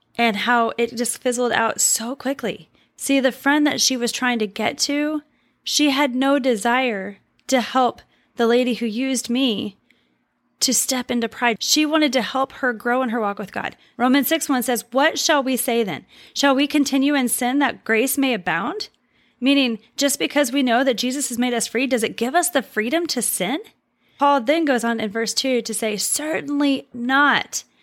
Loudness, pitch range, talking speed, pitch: -20 LUFS, 235-280 Hz, 200 wpm, 255 Hz